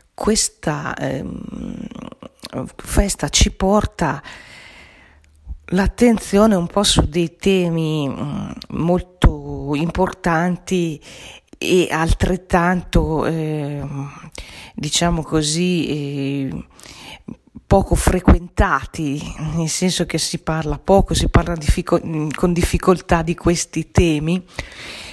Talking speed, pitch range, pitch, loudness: 85 wpm, 150-185 Hz, 170 Hz, -19 LUFS